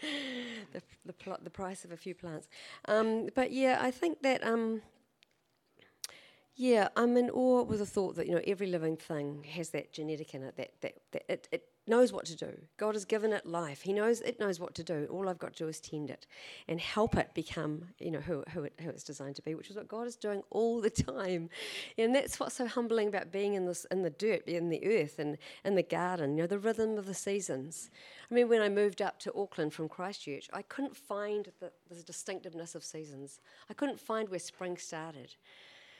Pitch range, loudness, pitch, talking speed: 165-225 Hz, -35 LUFS, 195 Hz, 225 wpm